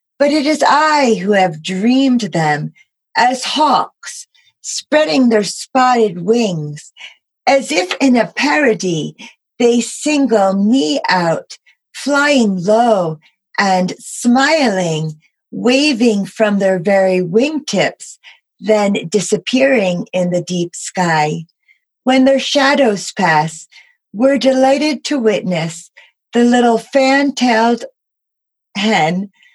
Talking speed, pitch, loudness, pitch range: 100 wpm, 225 Hz, -14 LUFS, 185-270 Hz